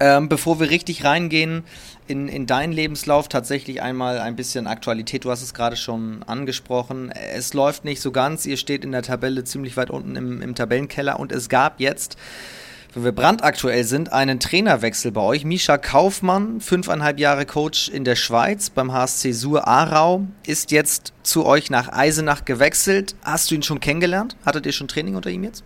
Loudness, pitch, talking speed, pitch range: -20 LUFS, 140 Hz, 180 wpm, 125-155 Hz